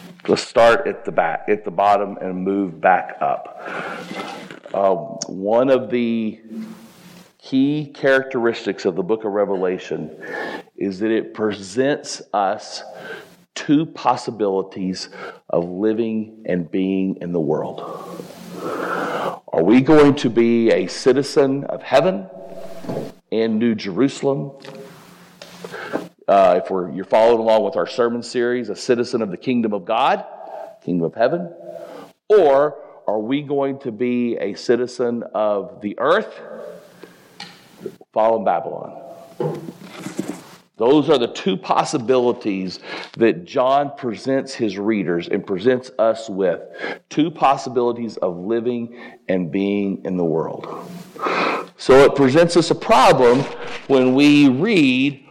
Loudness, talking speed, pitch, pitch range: -19 LUFS, 125 wpm, 120 Hz, 100-135 Hz